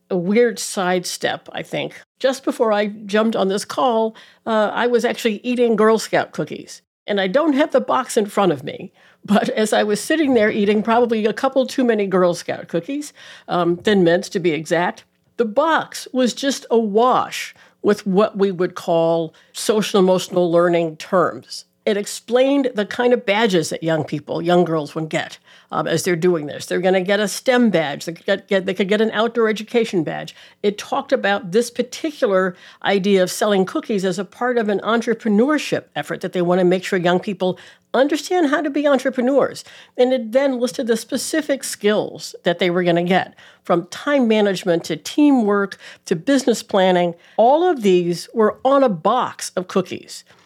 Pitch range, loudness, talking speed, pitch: 180-245 Hz, -19 LUFS, 185 wpm, 210 Hz